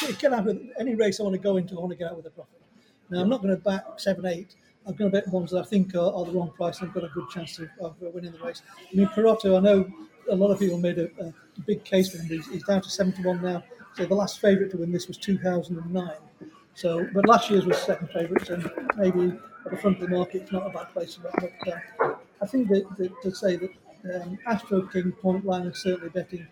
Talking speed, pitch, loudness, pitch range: 275 wpm, 185 Hz, -26 LUFS, 175-200 Hz